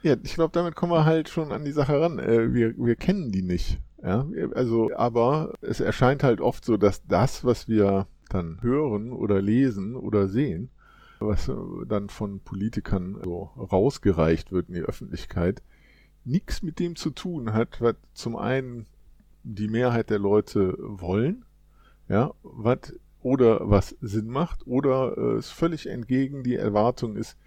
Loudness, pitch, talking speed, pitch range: -25 LUFS, 115 Hz, 155 wpm, 105-140 Hz